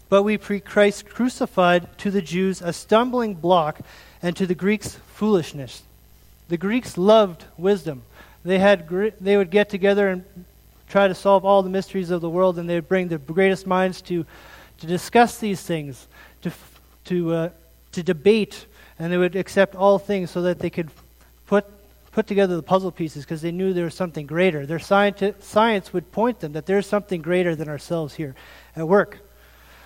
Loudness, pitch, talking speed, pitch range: -21 LUFS, 185 Hz, 185 wpm, 170-200 Hz